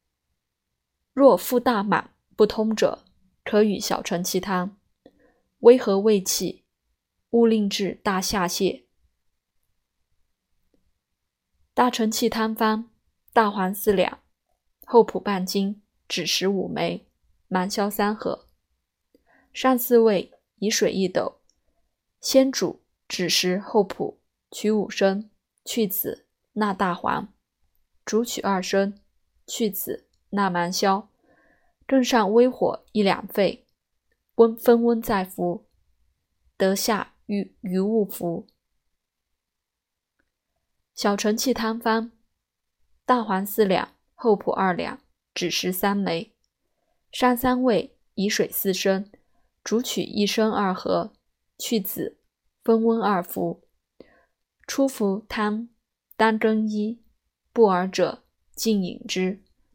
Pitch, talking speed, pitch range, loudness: 205 Hz, 140 characters per minute, 185-225 Hz, -23 LUFS